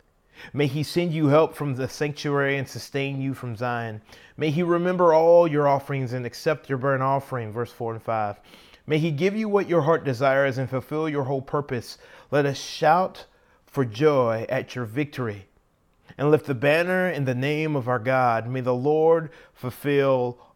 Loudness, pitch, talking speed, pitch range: -24 LUFS, 140 Hz, 185 wpm, 125-155 Hz